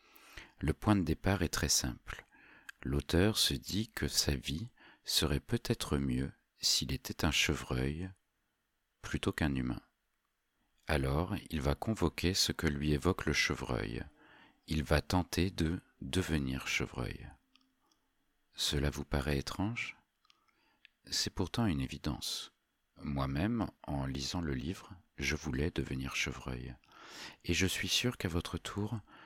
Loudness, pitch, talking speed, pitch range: -35 LUFS, 80 Hz, 130 wpm, 70-95 Hz